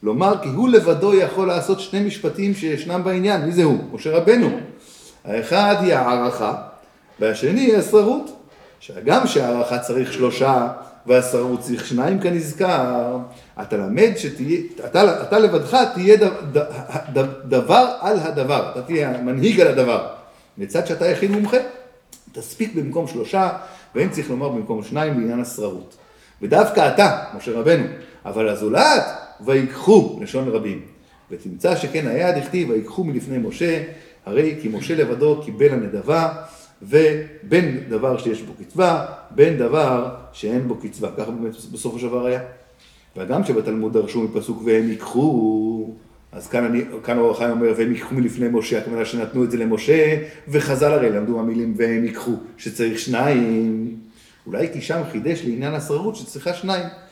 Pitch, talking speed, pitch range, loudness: 145 Hz, 140 wpm, 120-185 Hz, -19 LUFS